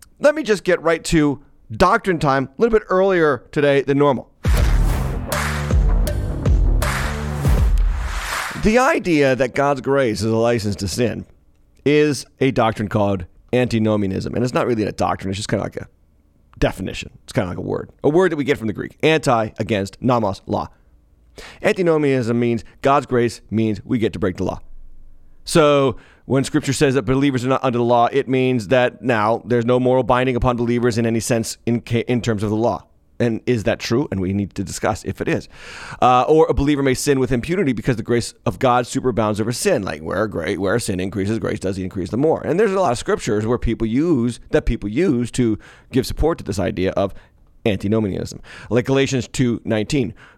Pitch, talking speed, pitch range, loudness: 120 Hz, 200 wpm, 95-135 Hz, -19 LUFS